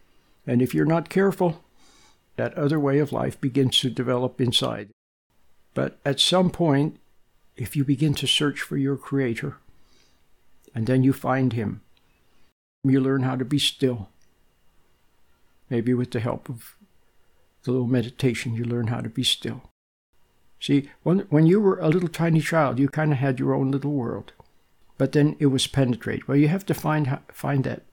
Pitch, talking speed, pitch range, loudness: 135 Hz, 175 wpm, 115-145 Hz, -23 LUFS